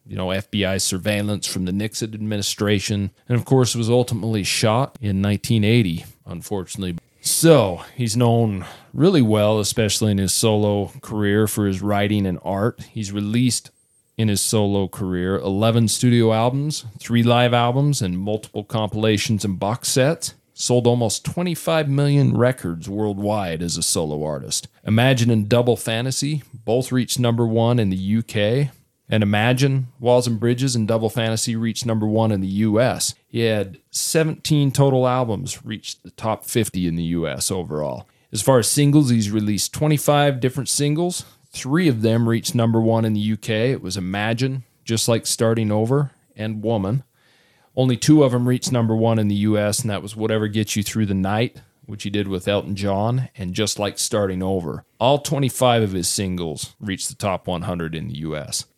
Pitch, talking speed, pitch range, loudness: 115 Hz, 170 wpm, 105-125 Hz, -20 LUFS